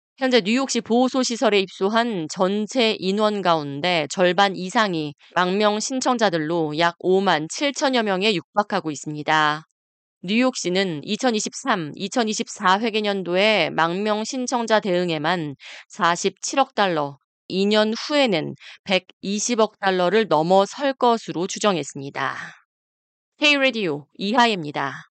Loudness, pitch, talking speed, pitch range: -21 LUFS, 200 Hz, 235 characters per minute, 170-230 Hz